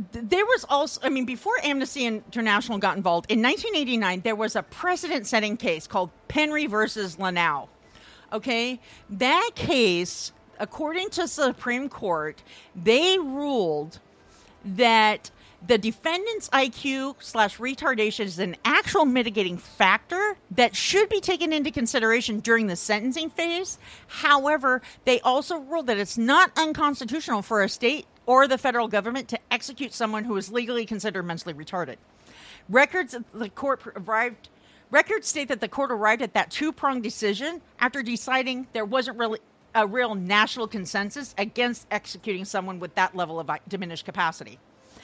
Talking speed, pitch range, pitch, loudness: 145 wpm, 210-280 Hz, 240 Hz, -24 LUFS